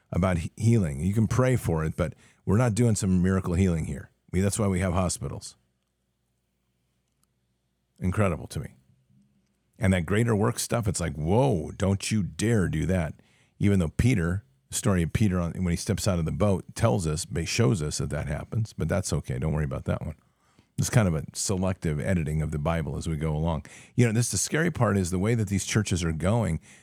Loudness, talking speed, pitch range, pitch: -27 LUFS, 210 wpm, 80-105 Hz, 95 Hz